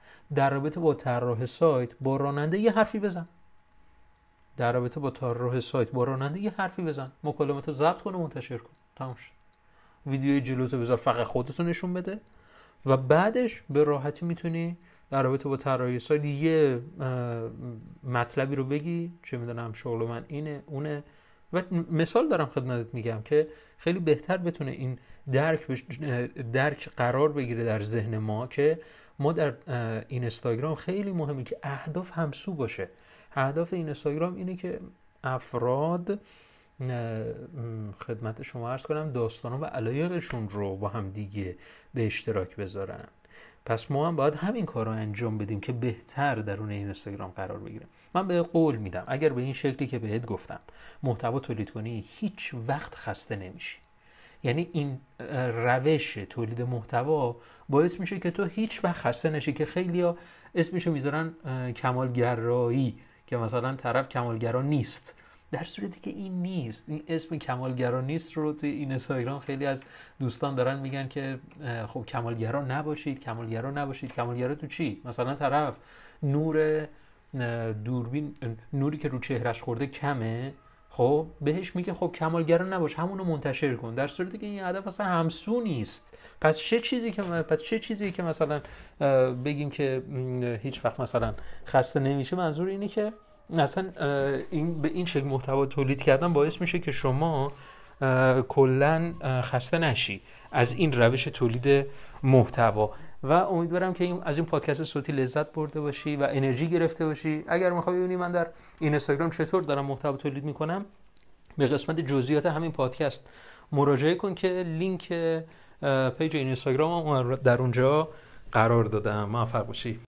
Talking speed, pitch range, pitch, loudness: 150 wpm, 125-160 Hz, 140 Hz, -29 LUFS